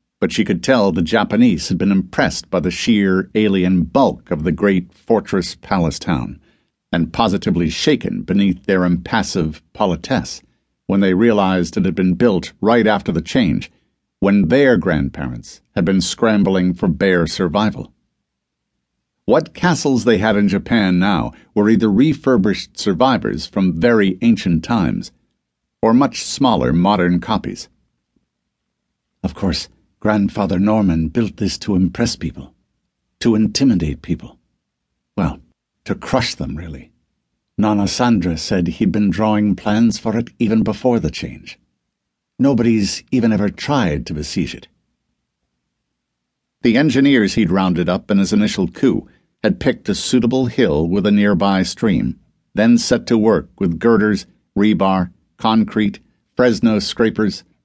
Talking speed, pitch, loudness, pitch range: 135 wpm, 100 Hz, -17 LUFS, 90-110 Hz